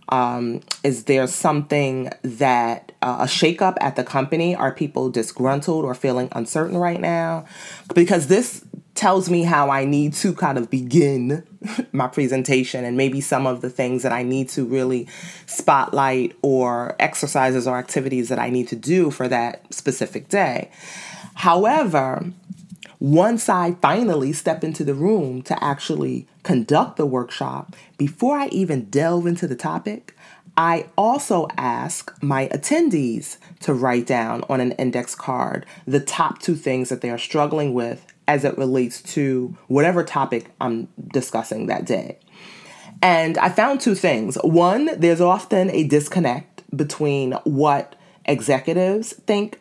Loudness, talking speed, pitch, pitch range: -20 LUFS, 150 wpm, 145 Hz, 130-175 Hz